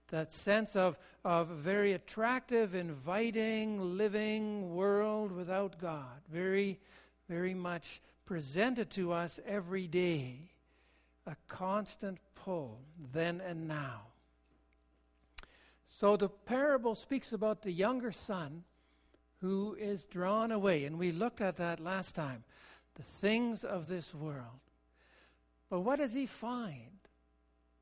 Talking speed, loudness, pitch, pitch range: 115 wpm, -36 LUFS, 185 Hz, 150-210 Hz